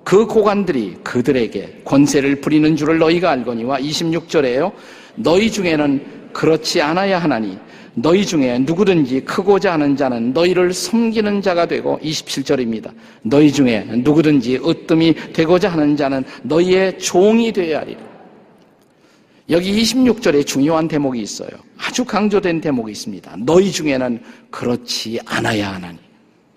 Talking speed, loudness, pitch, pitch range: 310 characters per minute, -16 LUFS, 160 Hz, 135-185 Hz